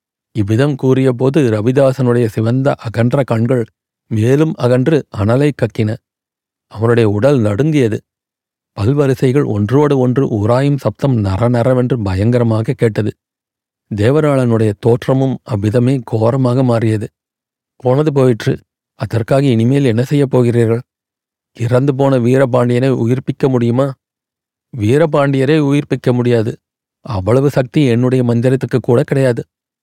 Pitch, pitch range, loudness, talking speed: 125 Hz, 115-135 Hz, -14 LUFS, 95 wpm